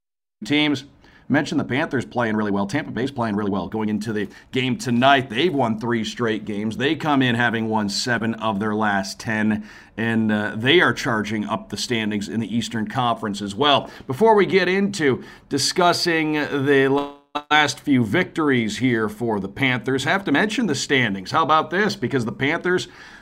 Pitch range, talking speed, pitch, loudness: 110-145 Hz, 185 wpm, 120 Hz, -21 LUFS